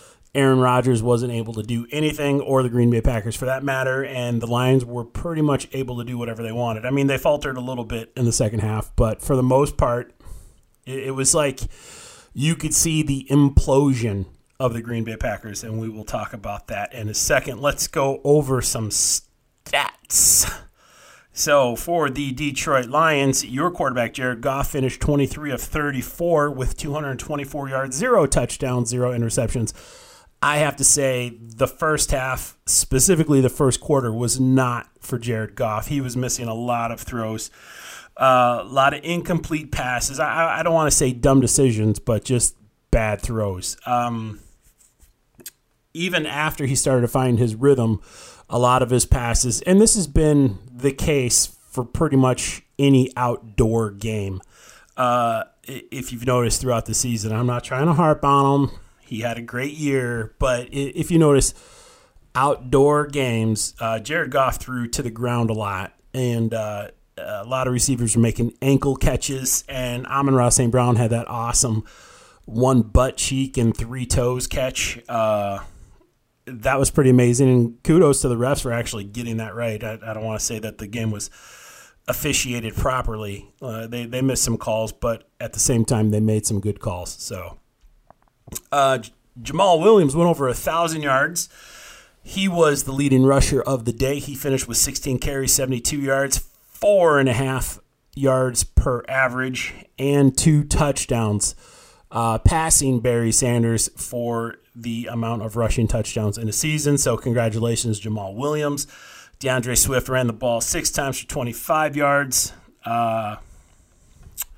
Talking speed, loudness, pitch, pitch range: 170 wpm, -20 LUFS, 125 Hz, 115-140 Hz